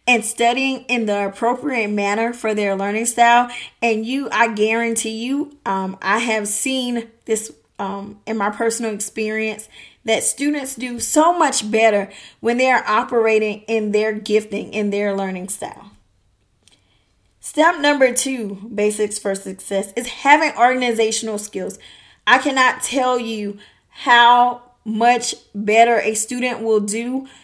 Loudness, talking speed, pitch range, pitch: -18 LUFS, 140 wpm, 210-245 Hz, 225 Hz